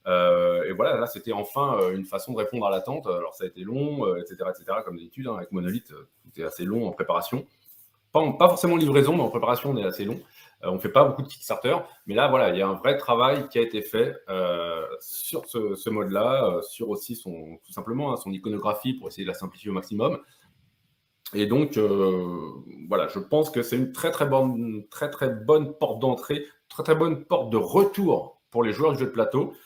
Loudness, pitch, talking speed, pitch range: -25 LUFS, 125 Hz, 235 wpm, 100-145 Hz